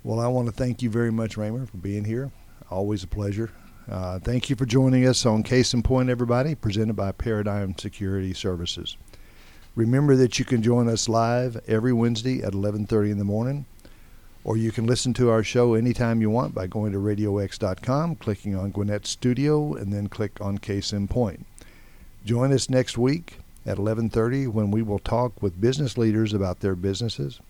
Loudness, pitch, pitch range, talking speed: -24 LUFS, 110 Hz, 100-125 Hz, 190 wpm